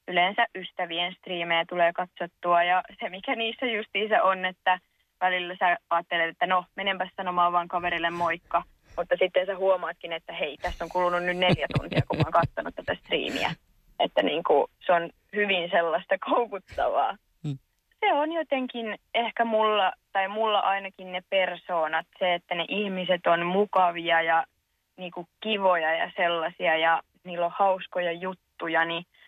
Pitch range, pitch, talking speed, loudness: 170-195 Hz, 180 Hz, 150 wpm, -26 LUFS